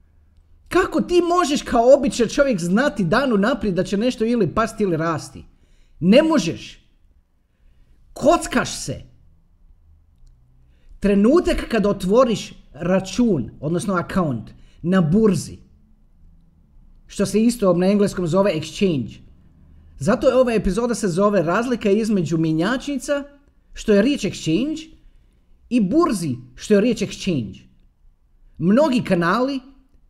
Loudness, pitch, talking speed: -19 LUFS, 185 Hz, 110 wpm